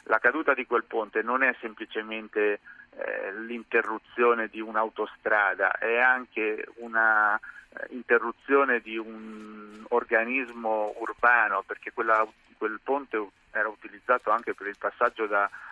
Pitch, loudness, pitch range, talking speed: 110 Hz, -27 LUFS, 110-120 Hz, 120 wpm